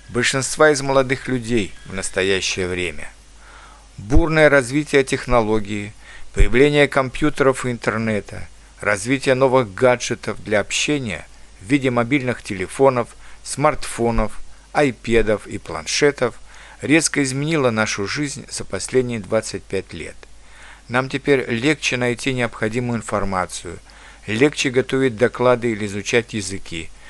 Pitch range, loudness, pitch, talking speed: 105-135 Hz, -19 LUFS, 120 Hz, 105 wpm